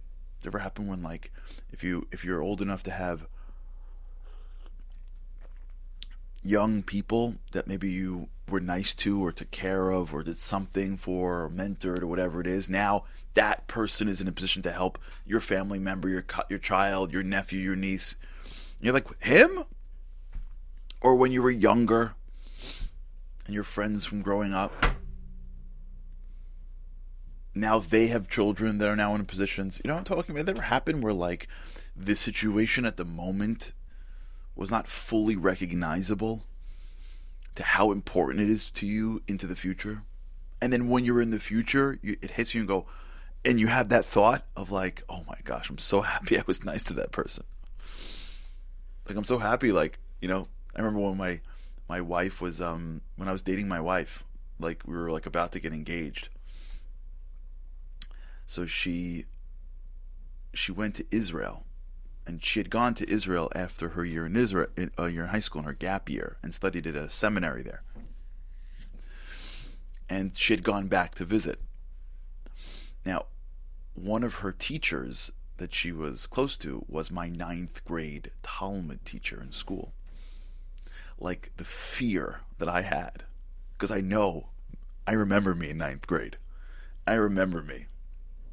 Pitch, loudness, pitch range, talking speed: 85 Hz, -29 LUFS, 65-100 Hz, 165 wpm